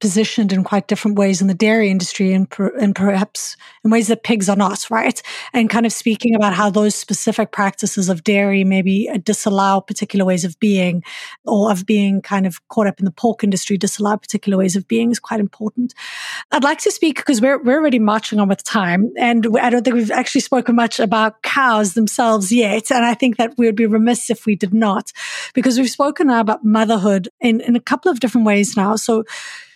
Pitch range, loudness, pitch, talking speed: 200-235 Hz, -16 LUFS, 220 Hz, 215 wpm